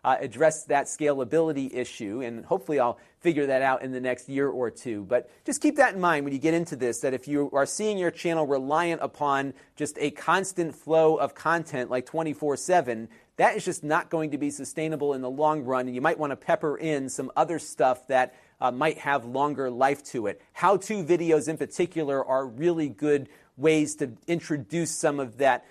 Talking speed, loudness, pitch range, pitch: 205 wpm, -27 LUFS, 135-160 Hz, 150 Hz